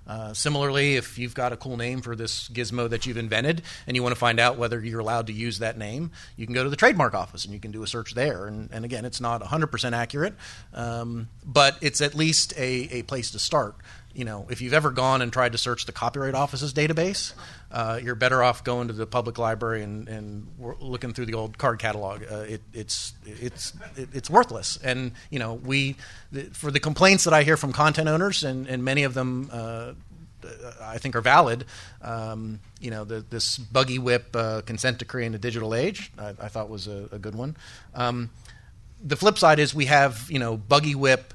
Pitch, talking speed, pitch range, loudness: 120 Hz, 220 wpm, 115-135 Hz, -24 LUFS